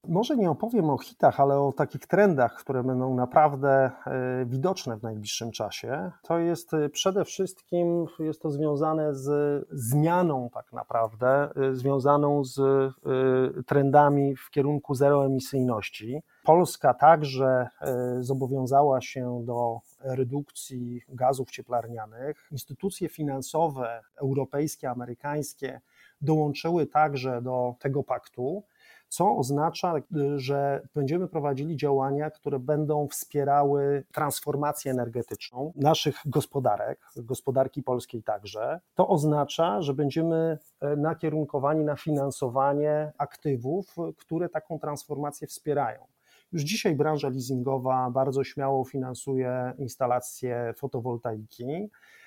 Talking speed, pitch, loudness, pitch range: 100 wpm, 140 Hz, -27 LUFS, 130-150 Hz